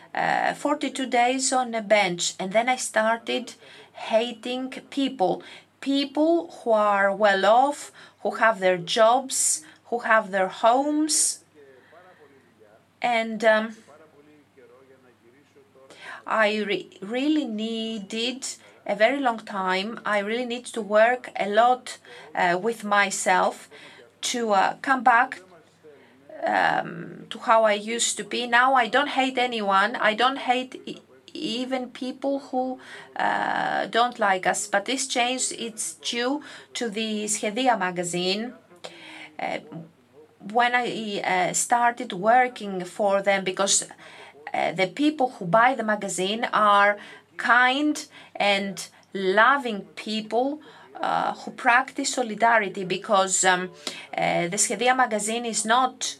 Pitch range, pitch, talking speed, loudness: 205-255 Hz, 230 Hz, 120 wpm, -23 LUFS